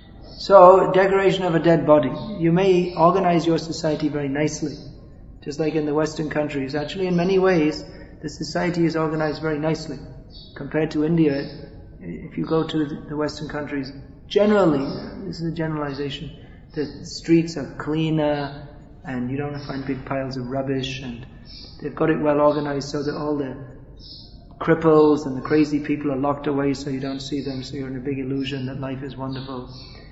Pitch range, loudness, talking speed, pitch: 140-160 Hz, -21 LUFS, 175 wpm, 150 Hz